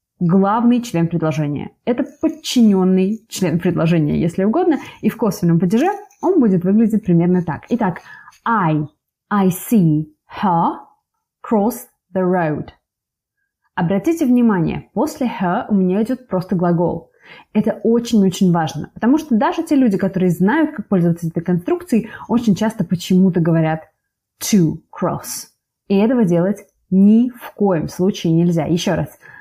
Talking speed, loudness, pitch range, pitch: 135 wpm, -17 LUFS, 175-235 Hz, 195 Hz